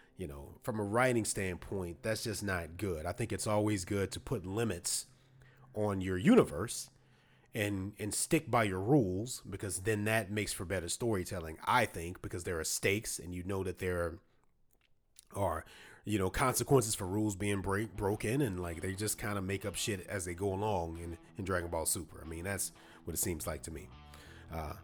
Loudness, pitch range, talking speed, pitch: -35 LUFS, 90-110 Hz, 200 wpm, 100 Hz